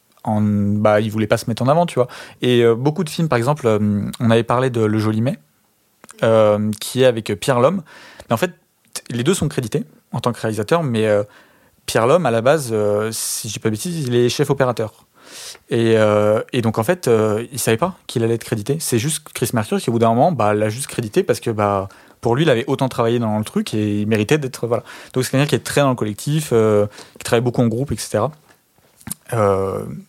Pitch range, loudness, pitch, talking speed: 110-135 Hz, -18 LUFS, 115 Hz, 240 wpm